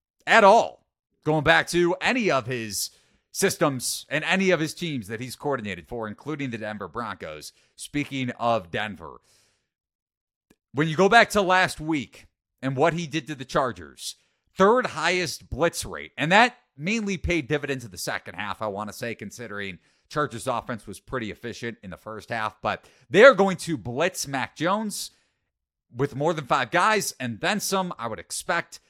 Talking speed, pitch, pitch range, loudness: 175 wpm, 140 Hz, 110-170 Hz, -24 LUFS